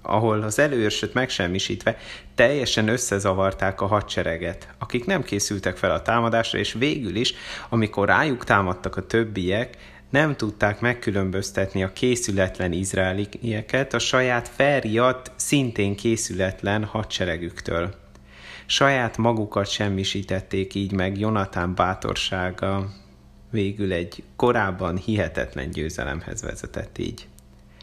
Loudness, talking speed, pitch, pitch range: -23 LUFS, 105 wpm, 100 Hz, 95-115 Hz